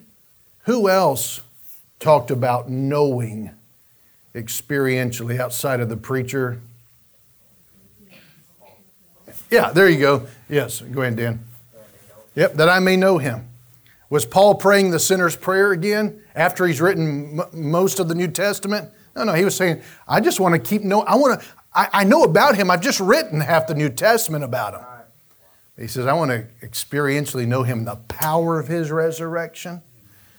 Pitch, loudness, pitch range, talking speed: 145 Hz, -19 LUFS, 120-180 Hz, 160 wpm